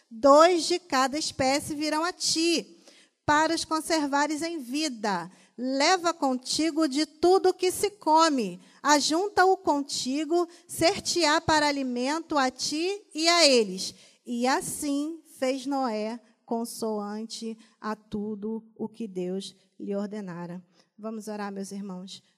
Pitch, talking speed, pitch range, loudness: 275 Hz, 125 wpm, 220-320 Hz, -26 LUFS